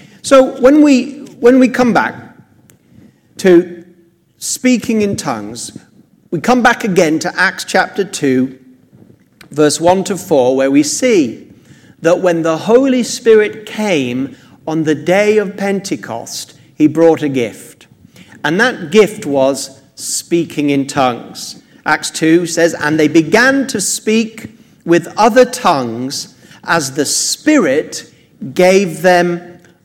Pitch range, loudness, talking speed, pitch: 155-220 Hz, -13 LUFS, 130 wpm, 175 Hz